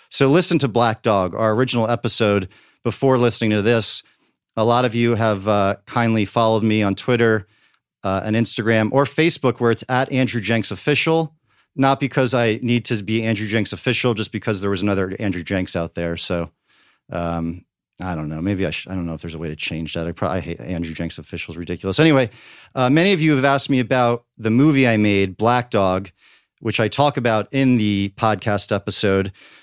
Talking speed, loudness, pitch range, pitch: 205 wpm, -19 LUFS, 95-120 Hz, 110 Hz